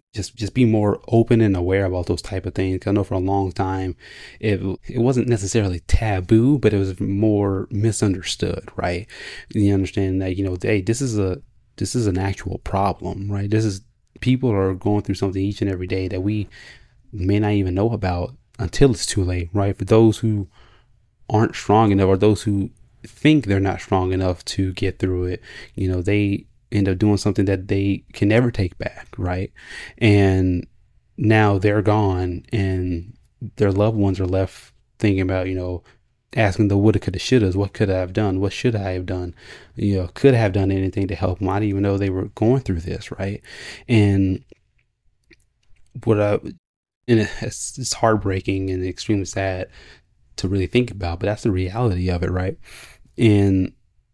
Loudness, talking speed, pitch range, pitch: -21 LUFS, 190 wpm, 95-110 Hz, 100 Hz